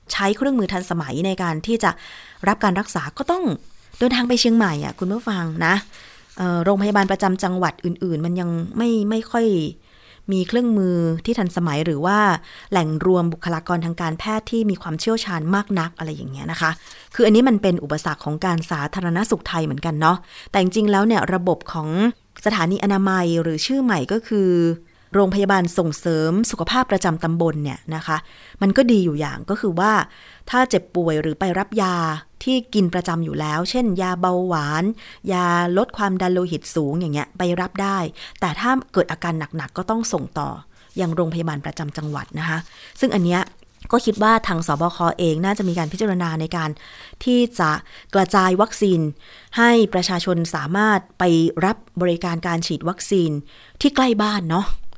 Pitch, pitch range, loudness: 180 Hz, 165-210 Hz, -20 LUFS